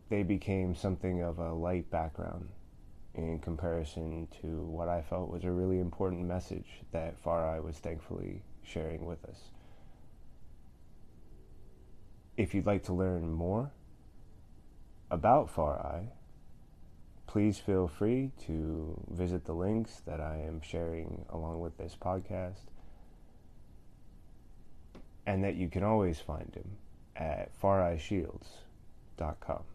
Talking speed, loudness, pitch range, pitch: 115 wpm, -36 LUFS, 80-95 Hz, 90 Hz